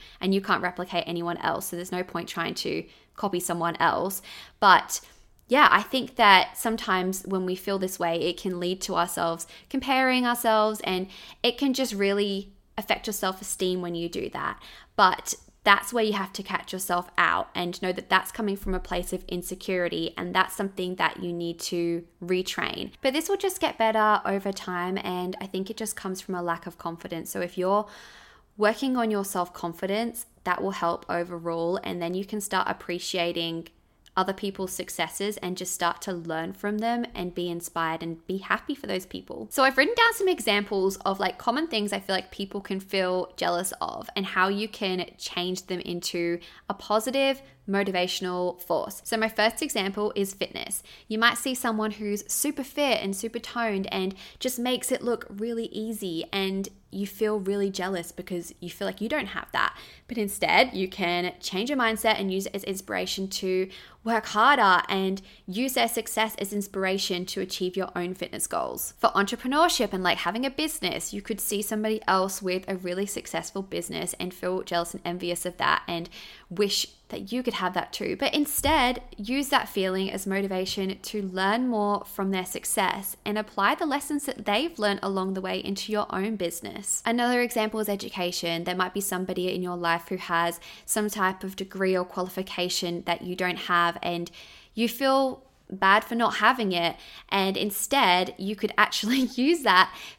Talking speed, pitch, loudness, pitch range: 190 wpm, 195 Hz, -27 LUFS, 180-220 Hz